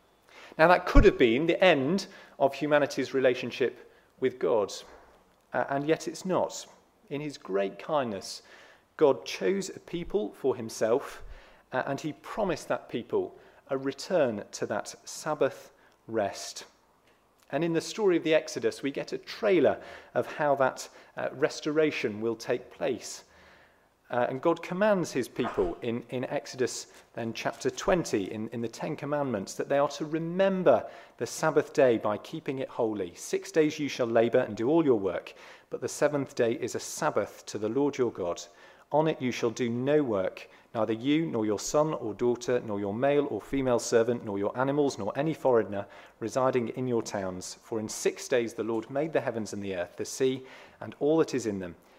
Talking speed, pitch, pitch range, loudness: 185 wpm, 135 Hz, 115-155 Hz, -29 LUFS